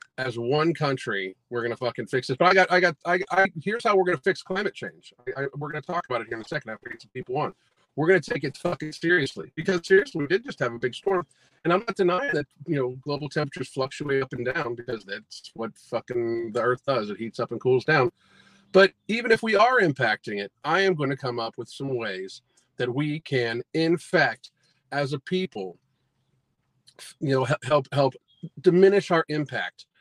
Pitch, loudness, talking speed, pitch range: 145 Hz, -25 LUFS, 220 wpm, 125-180 Hz